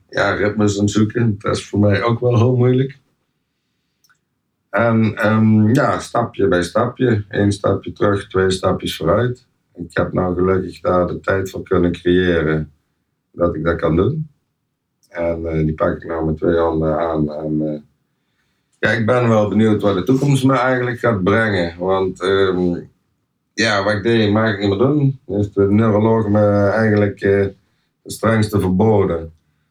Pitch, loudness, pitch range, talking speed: 100 Hz, -17 LUFS, 90-115 Hz, 165 wpm